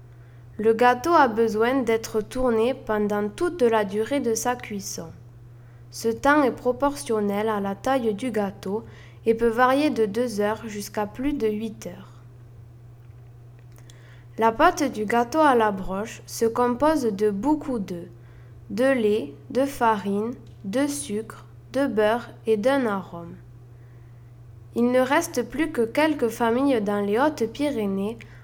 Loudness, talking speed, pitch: -24 LUFS, 140 wpm, 220 Hz